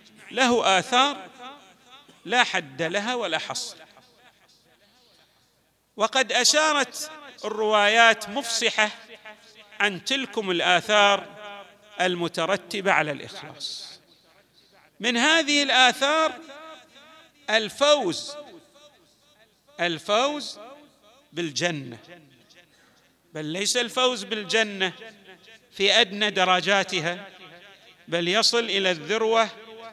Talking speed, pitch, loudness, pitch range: 70 wpm, 220 Hz, -22 LUFS, 190-255 Hz